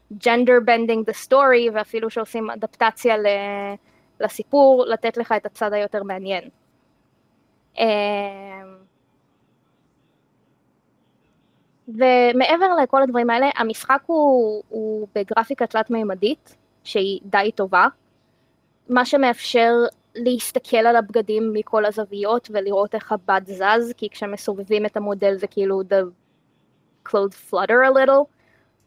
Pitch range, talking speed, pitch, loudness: 200-235 Hz, 100 wpm, 220 Hz, -19 LUFS